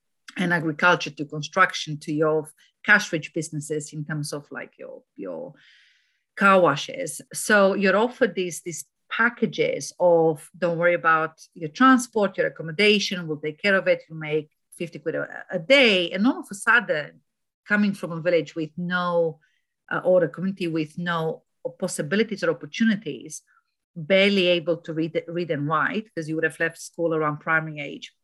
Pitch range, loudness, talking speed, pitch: 160-200 Hz, -23 LUFS, 165 wpm, 175 Hz